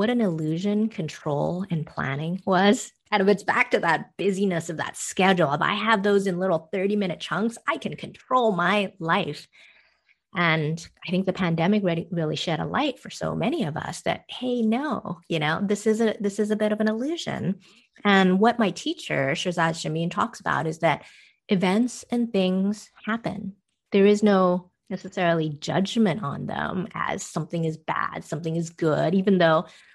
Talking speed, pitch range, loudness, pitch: 180 wpm, 165-210 Hz, -24 LUFS, 190 Hz